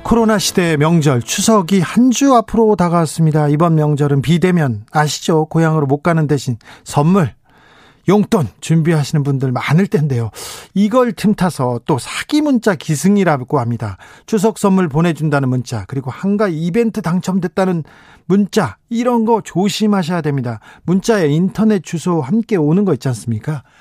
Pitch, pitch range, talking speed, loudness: 170 Hz, 145-200 Hz, 335 characters per minute, -15 LUFS